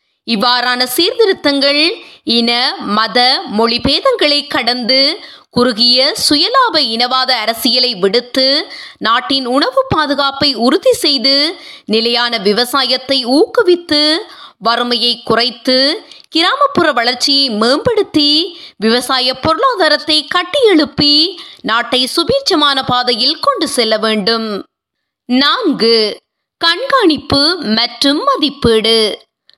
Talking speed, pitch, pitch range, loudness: 75 wpm, 270 Hz, 240-310 Hz, -11 LUFS